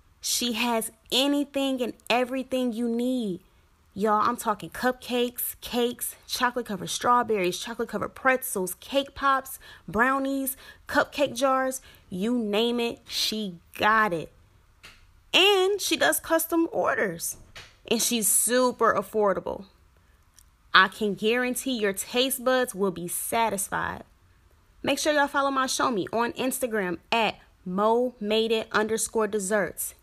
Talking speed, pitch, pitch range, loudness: 125 wpm, 235 Hz, 200-255 Hz, -25 LUFS